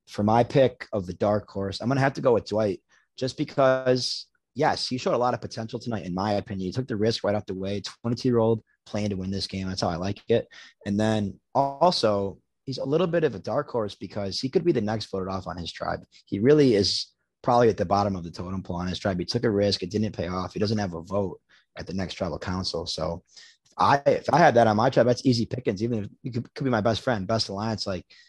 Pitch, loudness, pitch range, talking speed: 105 Hz, -26 LUFS, 95-120 Hz, 270 wpm